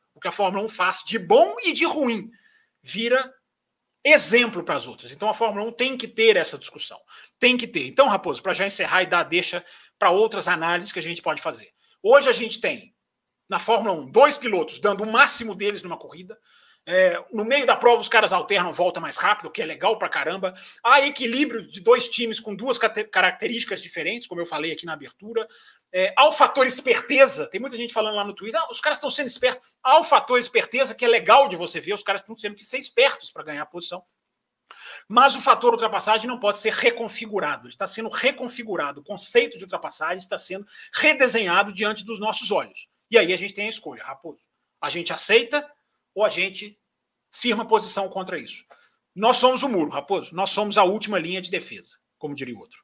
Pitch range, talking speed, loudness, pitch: 185-255 Hz, 210 wpm, -21 LUFS, 220 Hz